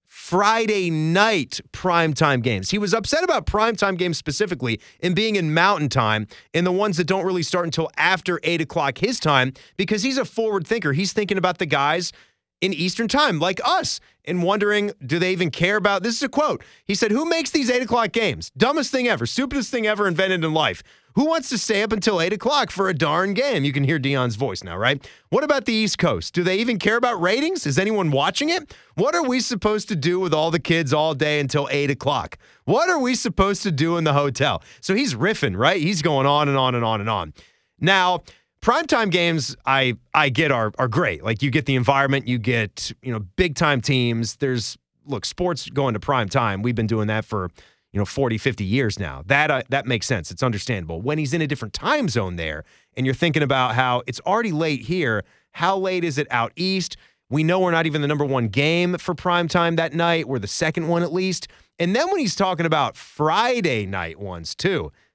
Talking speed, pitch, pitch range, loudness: 220 wpm, 165 Hz, 135-200 Hz, -21 LUFS